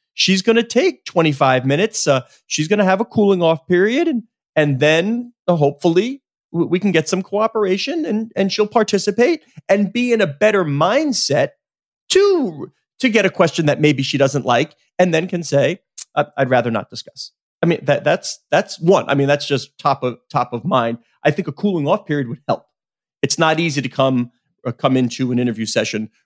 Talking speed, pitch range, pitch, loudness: 200 wpm, 140-210 Hz, 170 Hz, -17 LUFS